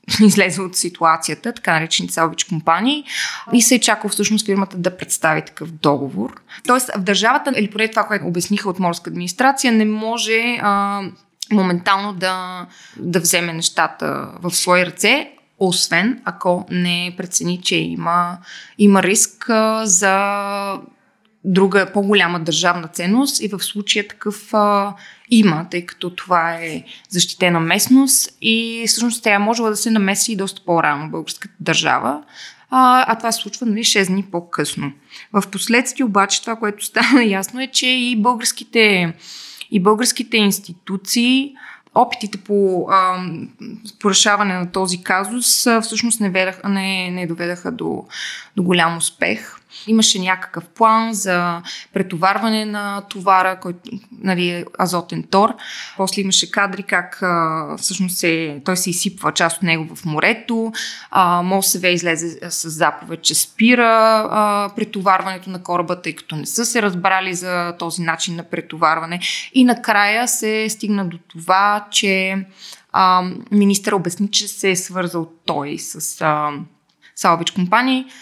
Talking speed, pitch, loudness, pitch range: 140 wpm, 195 Hz, -17 LUFS, 175-220 Hz